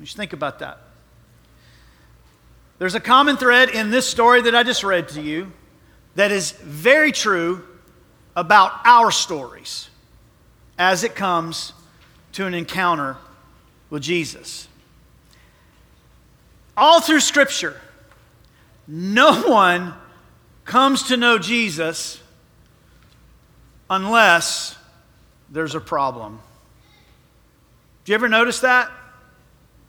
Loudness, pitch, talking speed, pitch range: -17 LUFS, 175 Hz, 100 wpm, 150-230 Hz